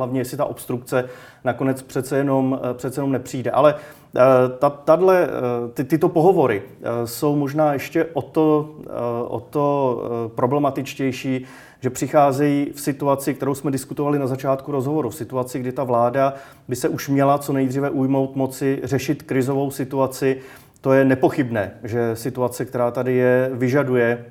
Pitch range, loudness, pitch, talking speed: 125-145 Hz, -21 LUFS, 135 Hz, 145 wpm